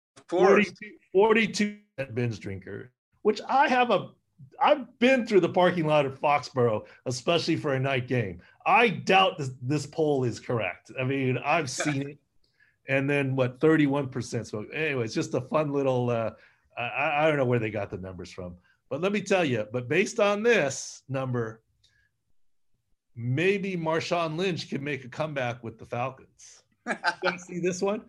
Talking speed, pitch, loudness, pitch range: 170 wpm, 145 Hz, -26 LUFS, 125-185 Hz